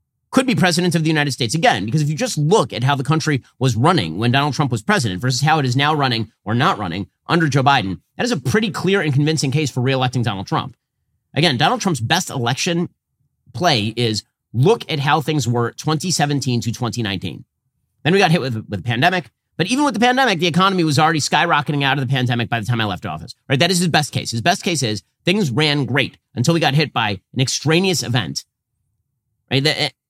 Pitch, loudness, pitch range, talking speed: 140 Hz, -18 LUFS, 120-160 Hz, 225 wpm